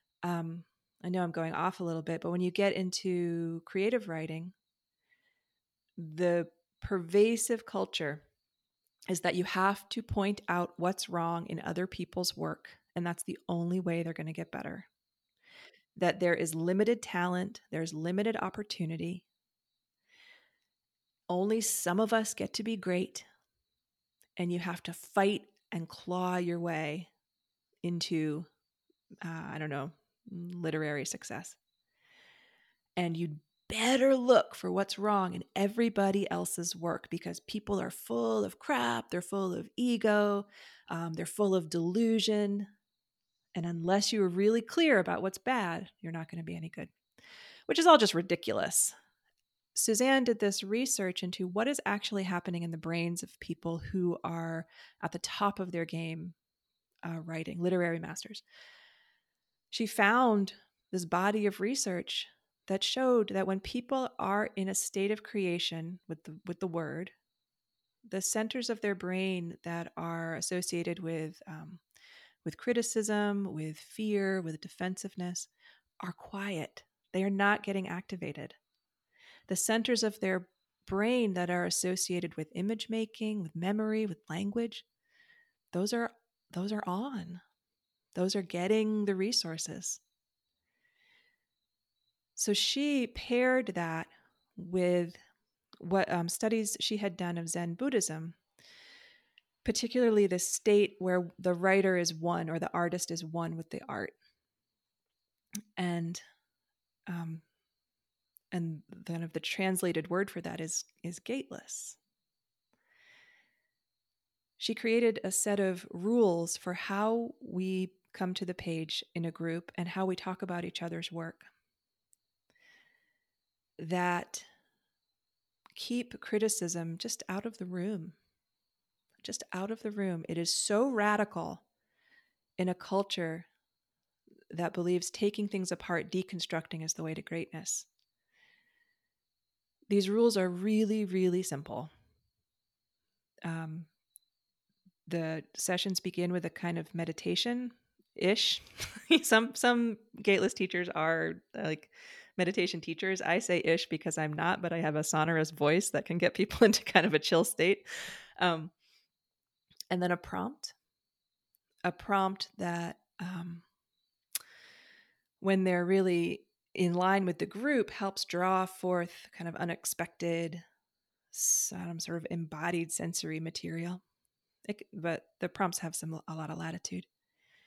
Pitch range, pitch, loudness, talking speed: 170-215 Hz, 185 Hz, -33 LUFS, 135 wpm